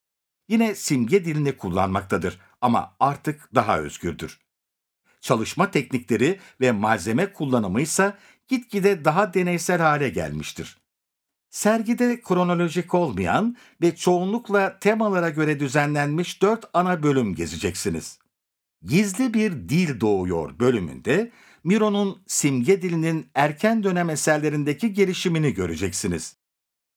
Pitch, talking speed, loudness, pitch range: 175 Hz, 100 wpm, -23 LUFS, 145-200 Hz